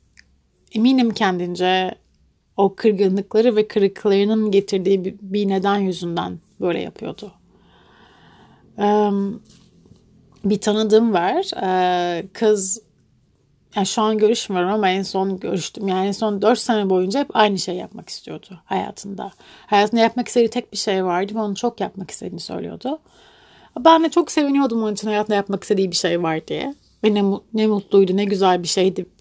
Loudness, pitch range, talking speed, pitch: -19 LUFS, 190-220 Hz, 145 wpm, 200 Hz